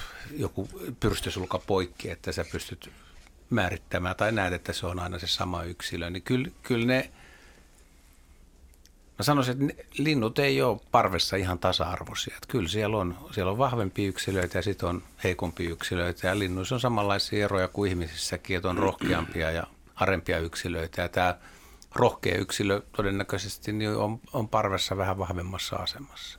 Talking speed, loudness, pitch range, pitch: 150 wpm, -29 LUFS, 85-105 Hz, 95 Hz